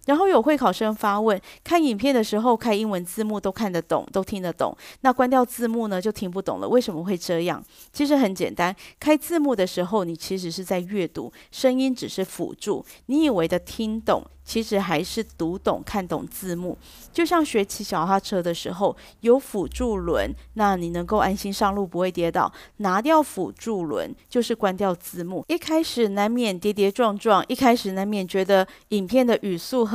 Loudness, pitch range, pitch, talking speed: -23 LUFS, 185-240 Hz, 205 Hz, 285 characters per minute